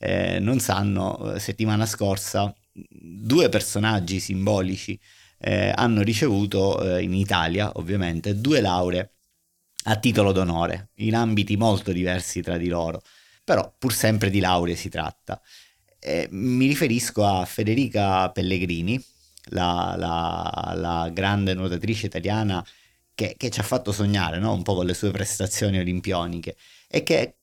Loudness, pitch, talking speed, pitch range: -24 LUFS, 100 Hz, 135 wpm, 90-105 Hz